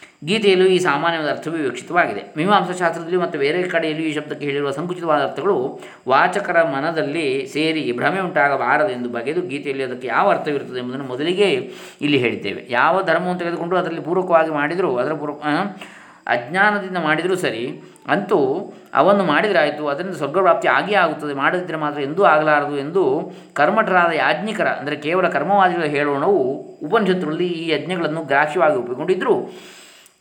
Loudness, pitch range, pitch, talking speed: -19 LUFS, 150-185 Hz, 165 Hz, 125 wpm